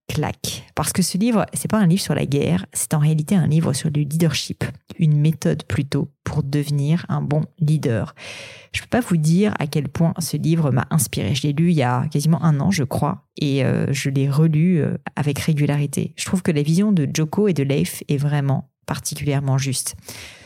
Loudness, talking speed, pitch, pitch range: -20 LUFS, 210 wpm, 150 Hz, 140-170 Hz